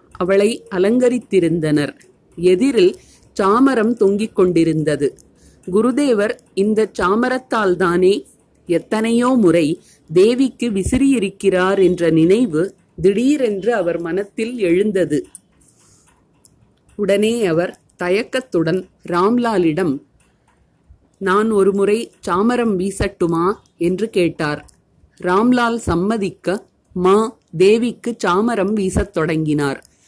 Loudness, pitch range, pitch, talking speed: -17 LUFS, 180-225 Hz, 195 Hz, 70 wpm